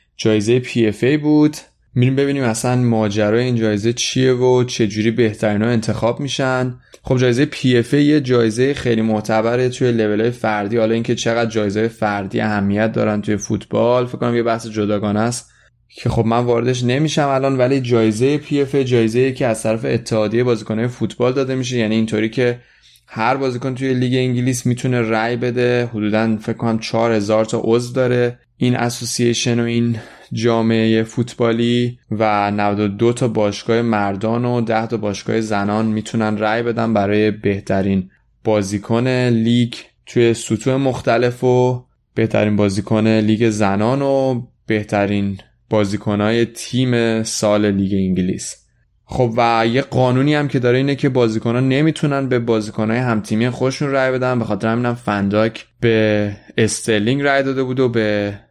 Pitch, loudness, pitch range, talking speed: 115 Hz, -17 LUFS, 110-125 Hz, 150 wpm